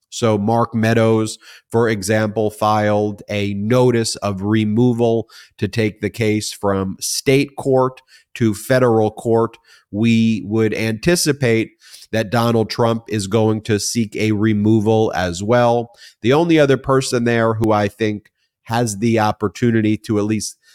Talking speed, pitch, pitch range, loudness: 140 wpm, 110 Hz, 105-120 Hz, -17 LUFS